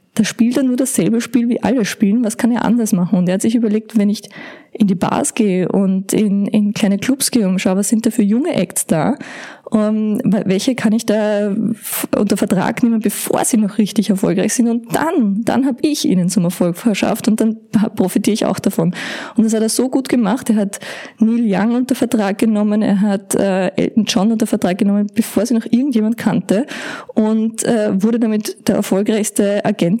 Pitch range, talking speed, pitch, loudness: 205-235 Hz, 200 wpm, 220 Hz, -16 LUFS